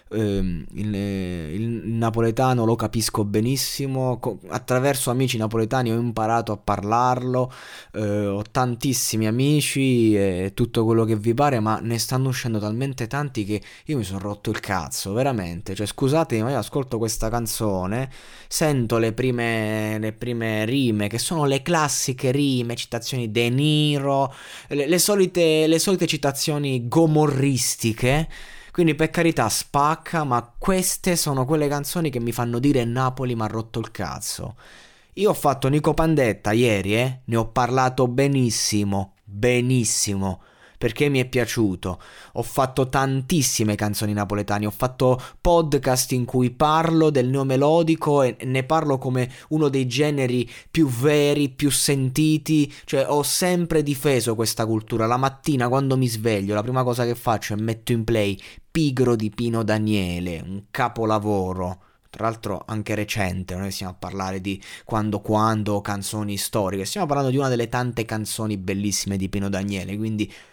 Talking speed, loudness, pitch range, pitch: 150 wpm, -22 LUFS, 110-140 Hz, 120 Hz